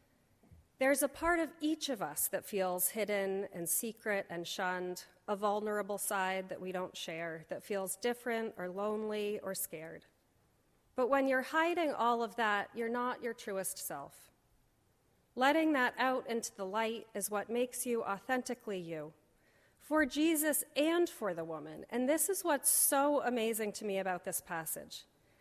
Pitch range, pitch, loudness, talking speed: 190-265 Hz, 220 Hz, -35 LUFS, 165 wpm